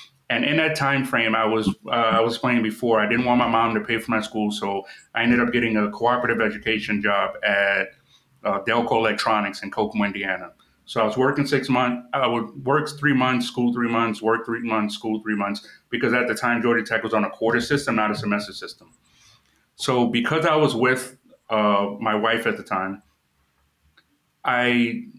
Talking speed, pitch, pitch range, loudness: 200 wpm, 115 Hz, 105-125 Hz, -22 LUFS